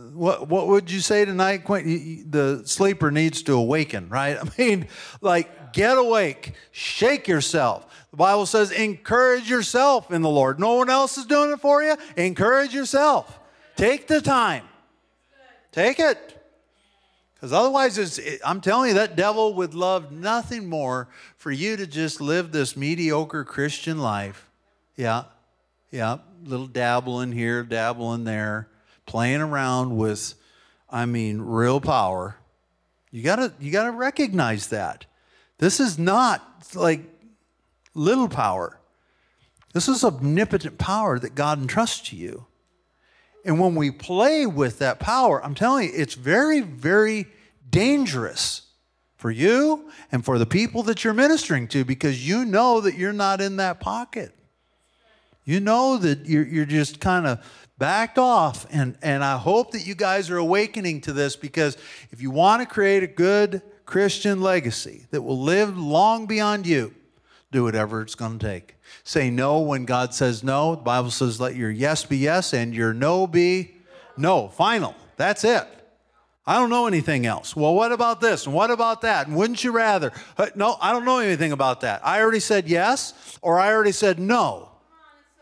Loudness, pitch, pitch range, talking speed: -22 LUFS, 170 Hz, 135-215 Hz, 160 wpm